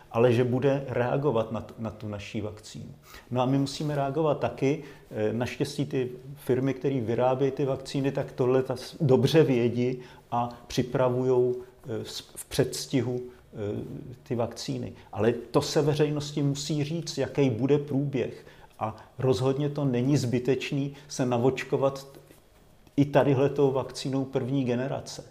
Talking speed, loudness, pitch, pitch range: 125 wpm, -28 LUFS, 130 Hz, 125-140 Hz